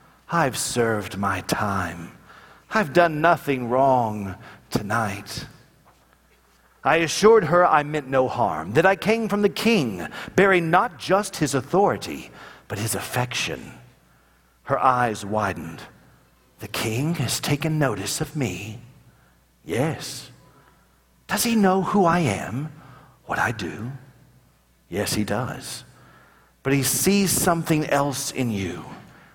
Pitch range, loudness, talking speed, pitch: 110-165 Hz, -22 LUFS, 125 wpm, 135 Hz